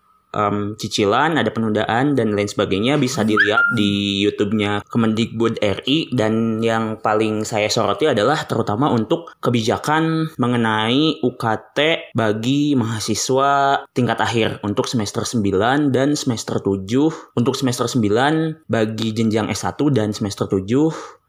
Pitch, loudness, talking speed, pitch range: 115 Hz, -19 LUFS, 120 wpm, 110-135 Hz